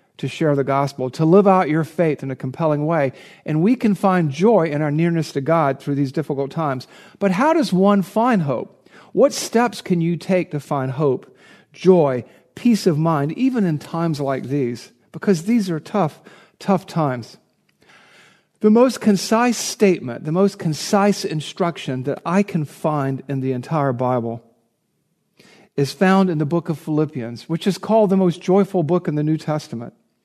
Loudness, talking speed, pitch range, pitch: -19 LUFS, 180 wpm, 145-195 Hz, 165 Hz